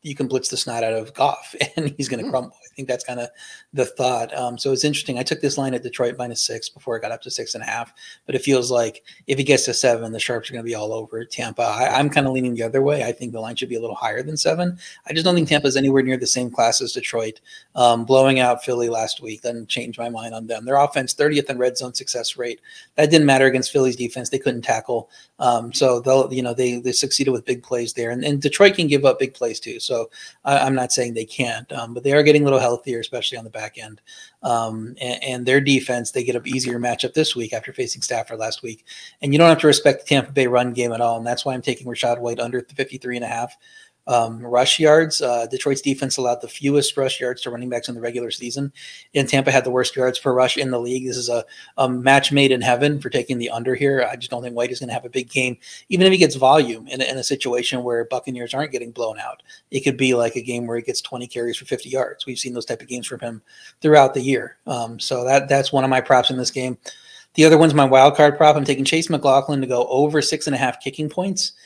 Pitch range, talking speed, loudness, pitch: 120-140 Hz, 275 wpm, -19 LUFS, 130 Hz